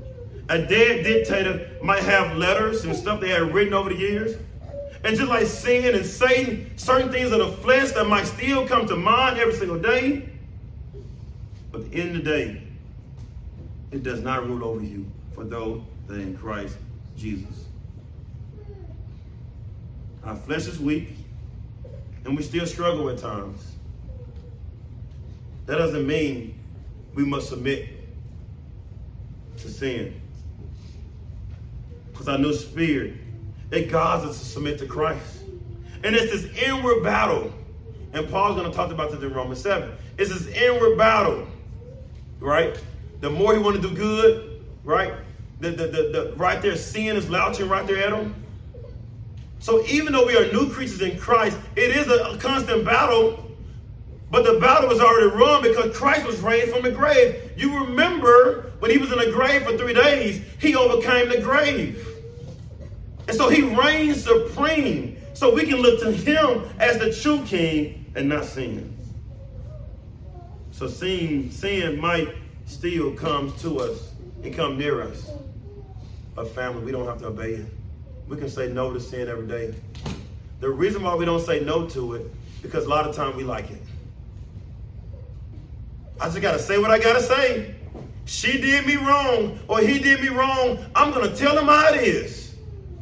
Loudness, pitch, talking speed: -21 LUFS, 150 Hz, 165 wpm